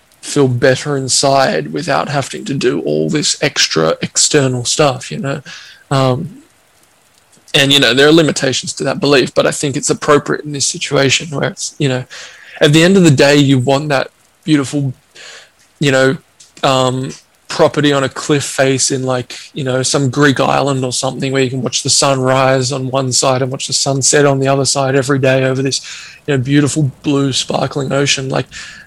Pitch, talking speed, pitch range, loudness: 135 Hz, 195 wpm, 130-145 Hz, -13 LUFS